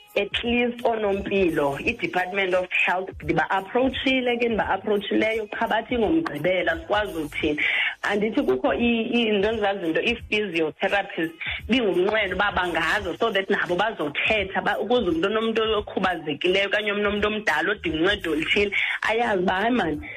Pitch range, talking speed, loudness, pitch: 185-235 Hz, 115 wpm, -23 LUFS, 205 Hz